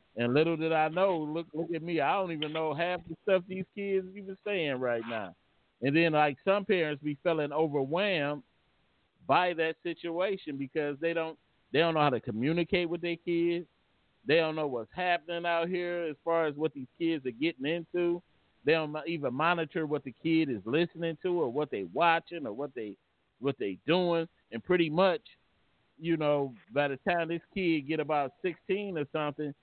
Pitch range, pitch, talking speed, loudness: 150-175 Hz, 165 Hz, 195 wpm, -31 LUFS